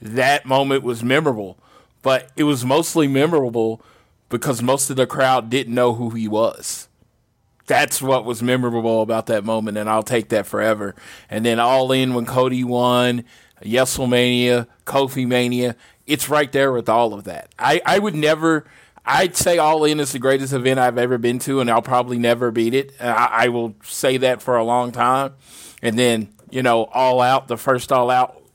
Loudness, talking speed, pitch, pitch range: -18 LUFS, 185 wpm, 125 Hz, 120-135 Hz